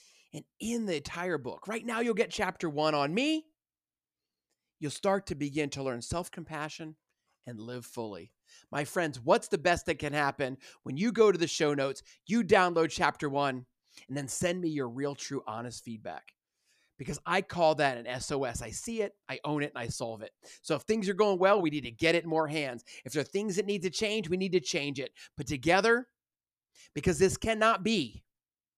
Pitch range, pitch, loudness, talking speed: 140-195 Hz, 160 Hz, -31 LUFS, 210 wpm